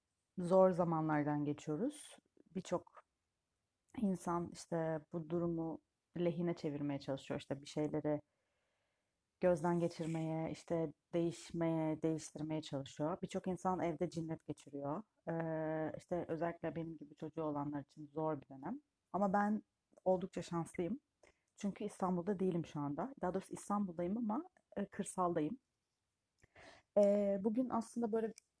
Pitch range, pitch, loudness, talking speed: 155-190 Hz, 170 Hz, -40 LUFS, 115 wpm